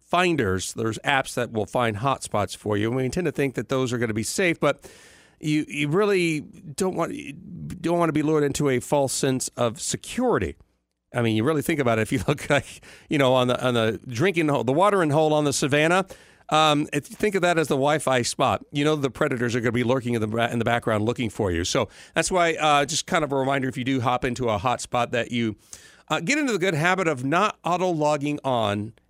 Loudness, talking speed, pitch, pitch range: -23 LUFS, 250 wpm, 140 Hz, 120-160 Hz